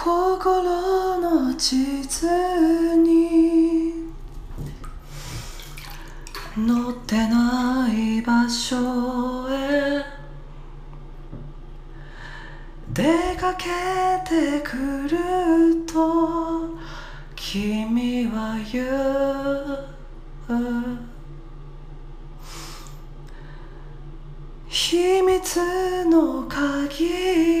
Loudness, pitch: -22 LUFS, 270 Hz